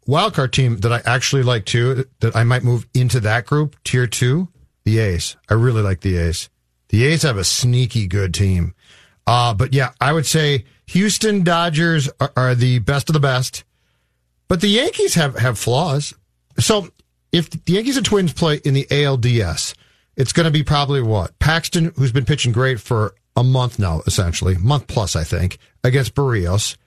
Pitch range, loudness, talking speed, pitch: 105-145 Hz, -17 LUFS, 185 wpm, 125 Hz